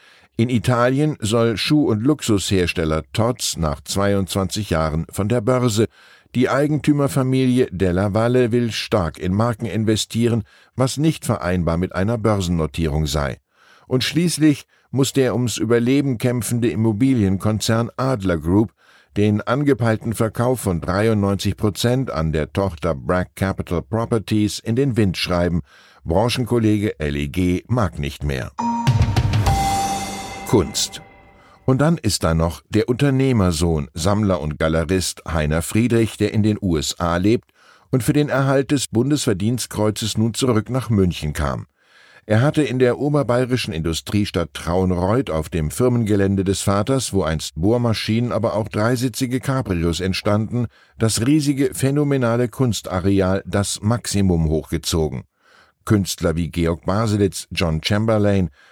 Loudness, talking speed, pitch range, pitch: -20 LUFS, 125 wpm, 90-125 Hz, 105 Hz